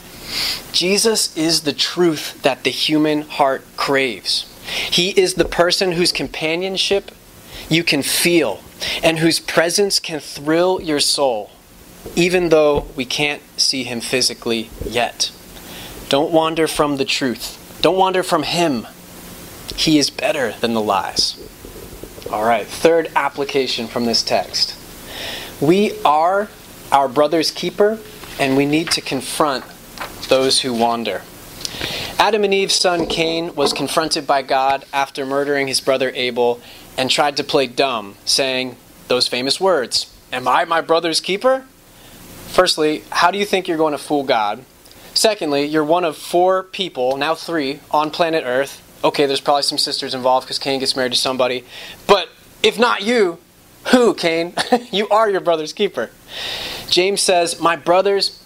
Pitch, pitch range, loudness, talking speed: 155 Hz, 135-175 Hz, -17 LUFS, 150 wpm